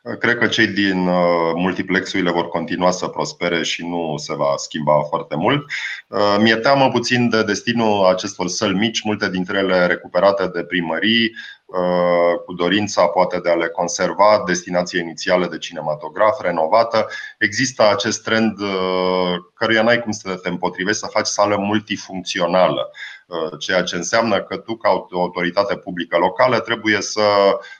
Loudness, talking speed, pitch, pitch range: -18 LUFS, 140 wpm, 95 Hz, 90-110 Hz